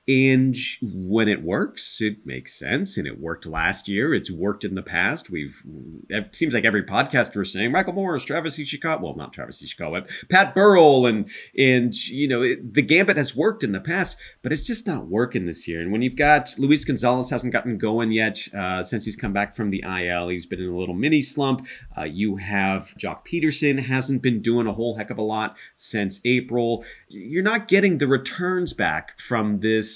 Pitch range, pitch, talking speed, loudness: 105-145 Hz, 120 Hz, 210 wpm, -22 LUFS